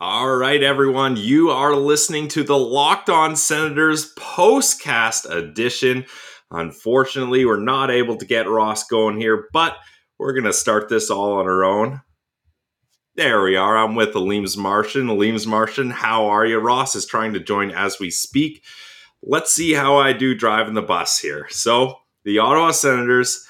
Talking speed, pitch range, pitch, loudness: 165 wpm, 110-145 Hz, 125 Hz, -18 LUFS